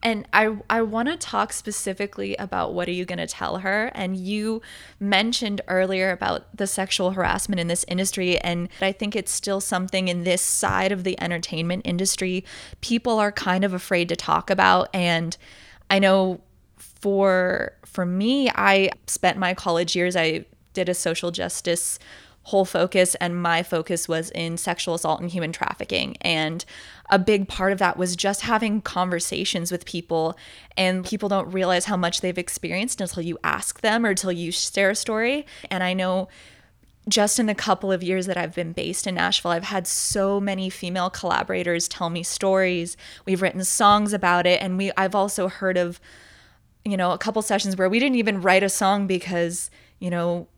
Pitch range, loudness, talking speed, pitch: 175-200 Hz, -23 LUFS, 185 wpm, 185 Hz